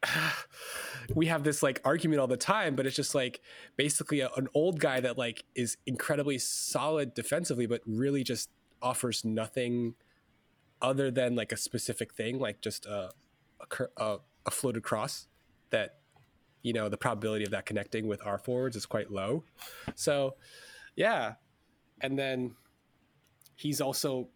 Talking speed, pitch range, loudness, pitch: 150 wpm, 115-145 Hz, -32 LUFS, 130 Hz